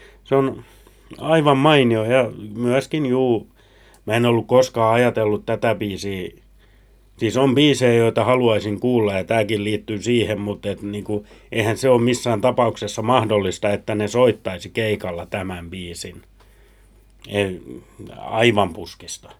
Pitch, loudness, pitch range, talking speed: 110 Hz, -19 LUFS, 105-125 Hz, 125 wpm